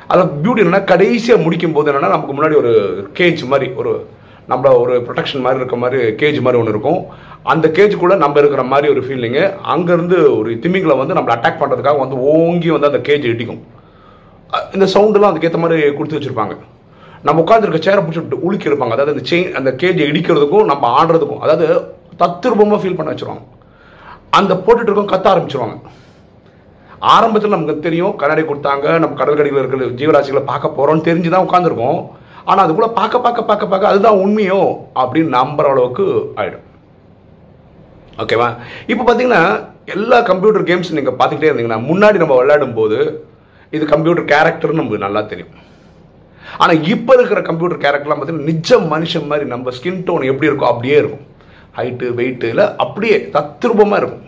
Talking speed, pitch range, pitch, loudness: 155 wpm, 145-210 Hz, 170 Hz, -13 LUFS